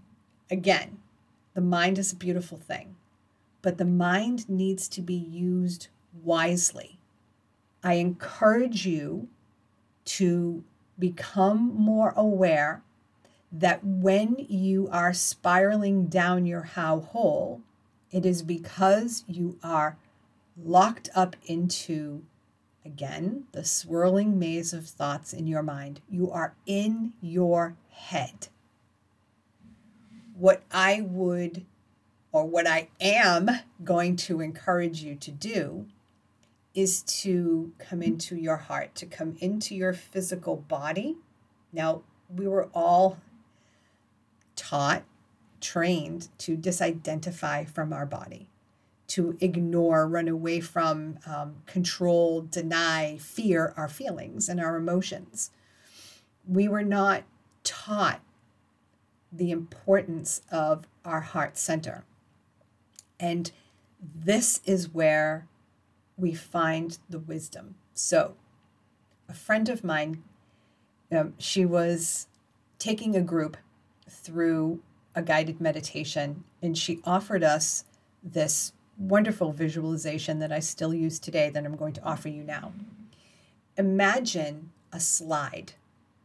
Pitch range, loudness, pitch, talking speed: 150-185 Hz, -27 LUFS, 170 Hz, 110 wpm